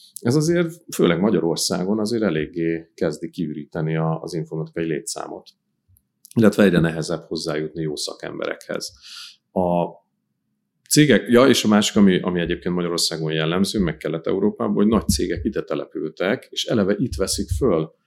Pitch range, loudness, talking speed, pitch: 80-100 Hz, -21 LUFS, 135 wpm, 85 Hz